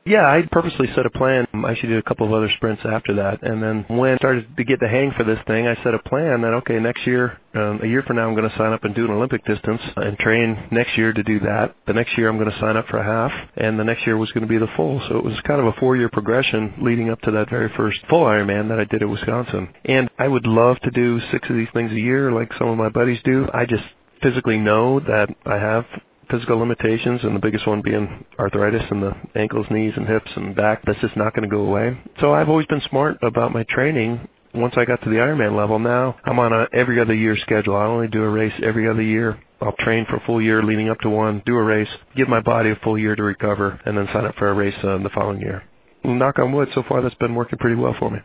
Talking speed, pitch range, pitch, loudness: 280 wpm, 105-120 Hz, 115 Hz, -19 LUFS